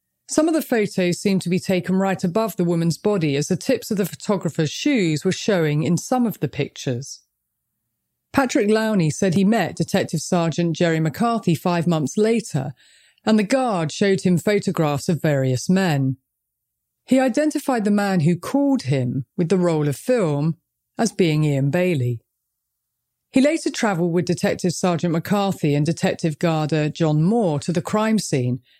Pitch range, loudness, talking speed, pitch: 155-210 Hz, -21 LUFS, 165 wpm, 175 Hz